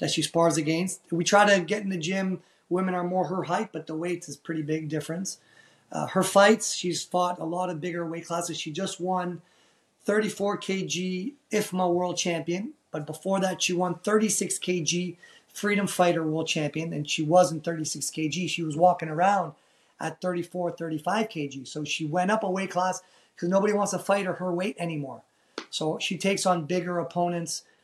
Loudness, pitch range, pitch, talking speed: -27 LUFS, 165-190 Hz, 180 Hz, 190 wpm